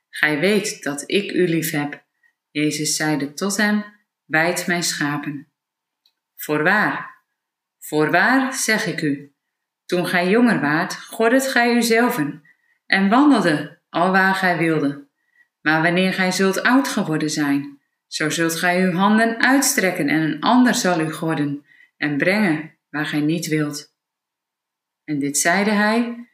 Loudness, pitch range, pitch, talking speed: -19 LUFS, 150-210 Hz, 175 Hz, 140 wpm